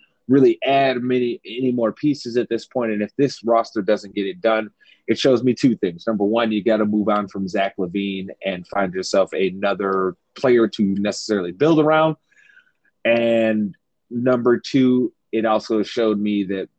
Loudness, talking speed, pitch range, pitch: -20 LUFS, 175 wpm, 100-125 Hz, 110 Hz